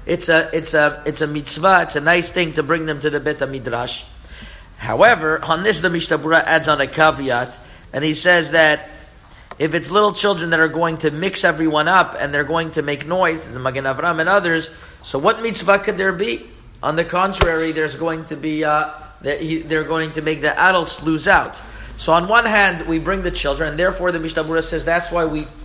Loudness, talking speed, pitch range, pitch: -17 LUFS, 215 wpm, 150-170 Hz, 160 Hz